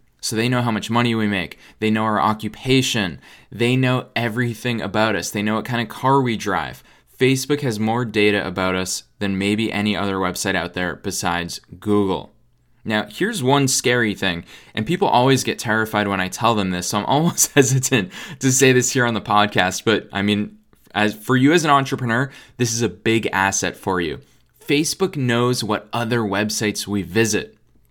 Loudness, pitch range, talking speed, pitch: -19 LUFS, 100-125 Hz, 190 wpm, 110 Hz